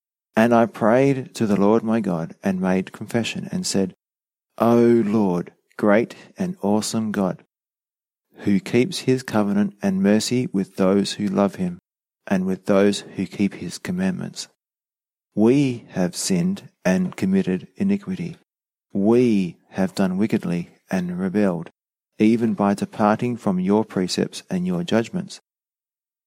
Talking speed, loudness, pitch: 135 wpm, -21 LUFS, 115 Hz